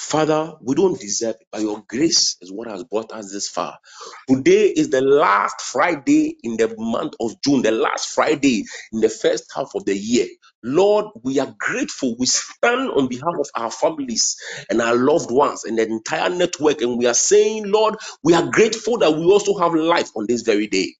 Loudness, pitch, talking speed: -19 LUFS, 170 Hz, 205 wpm